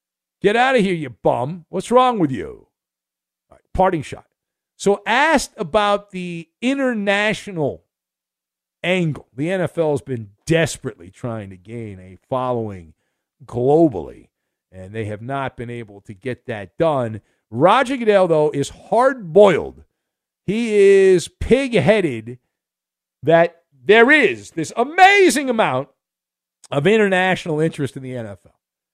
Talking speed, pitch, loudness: 125 wpm, 160 Hz, -17 LUFS